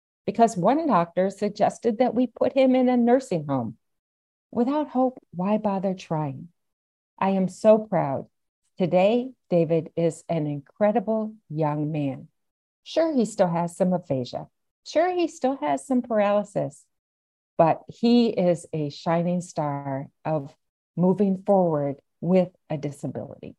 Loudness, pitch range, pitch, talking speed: -24 LUFS, 150-220 Hz, 180 Hz, 130 wpm